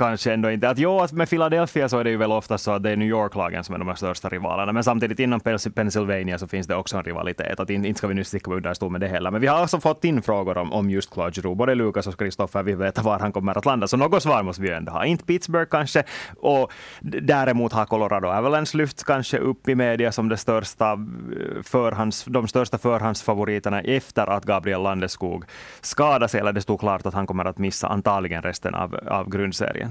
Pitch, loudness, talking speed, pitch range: 105 Hz, -23 LUFS, 235 wpm, 95-125 Hz